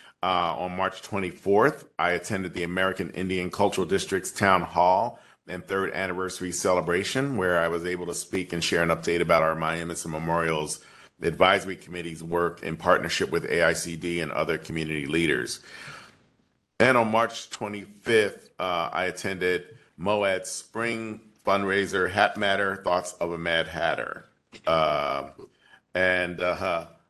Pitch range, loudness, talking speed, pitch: 85-95 Hz, -26 LUFS, 135 wpm, 90 Hz